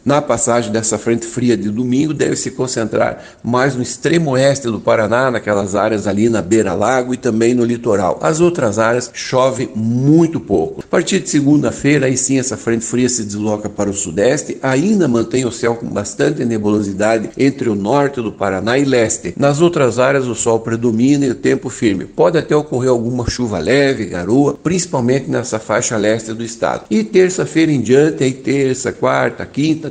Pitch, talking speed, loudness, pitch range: 125 Hz, 180 wpm, -15 LUFS, 115-140 Hz